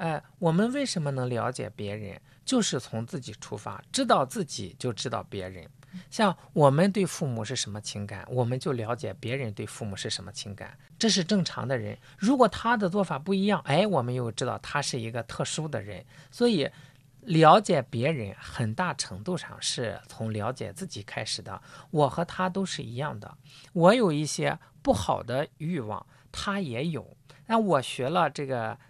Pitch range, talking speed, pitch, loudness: 115-175 Hz, 270 characters per minute, 140 Hz, -28 LUFS